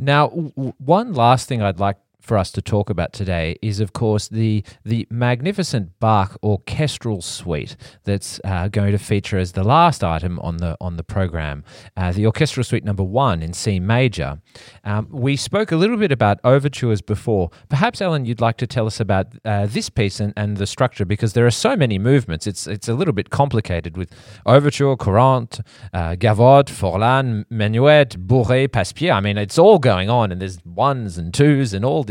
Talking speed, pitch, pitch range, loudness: 195 wpm, 110 Hz, 100-130 Hz, -18 LUFS